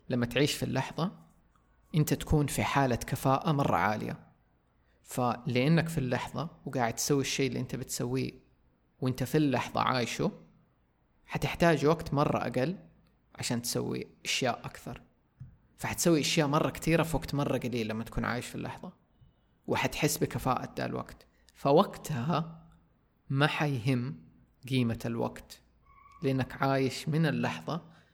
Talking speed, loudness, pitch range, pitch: 120 wpm, -31 LUFS, 120-155 Hz, 135 Hz